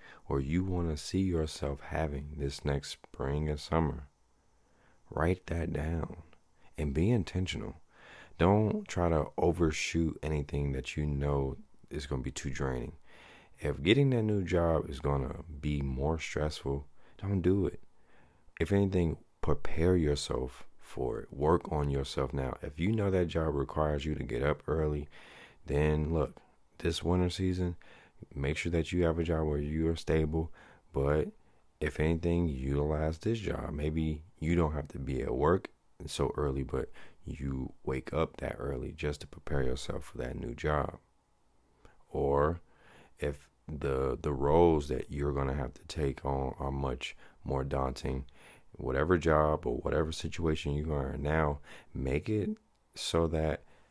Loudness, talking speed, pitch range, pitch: -33 LUFS, 160 wpm, 70-85 Hz, 75 Hz